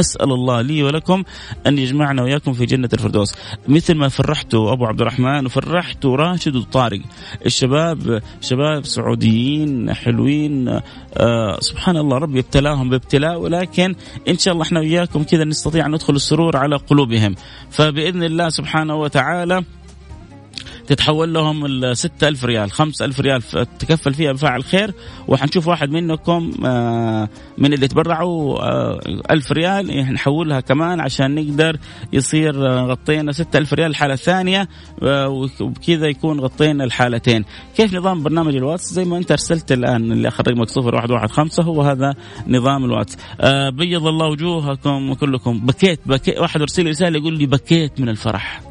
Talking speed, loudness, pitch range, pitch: 140 wpm, -17 LUFS, 125-160 Hz, 140 Hz